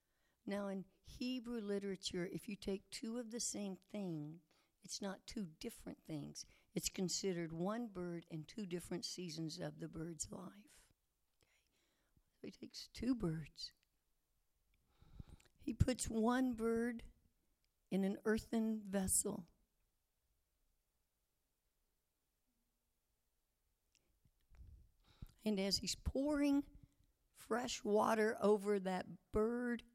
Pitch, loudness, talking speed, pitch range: 190 Hz, -42 LUFS, 105 wpm, 150-220 Hz